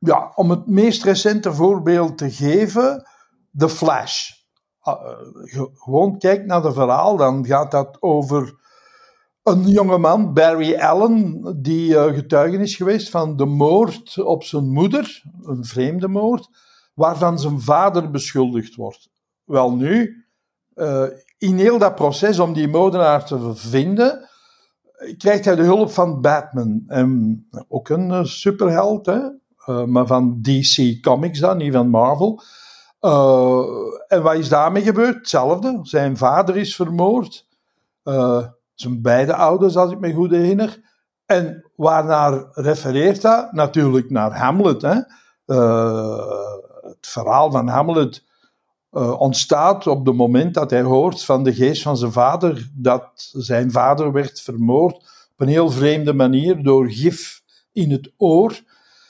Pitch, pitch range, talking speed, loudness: 160 Hz, 135-195 Hz, 135 wpm, -17 LUFS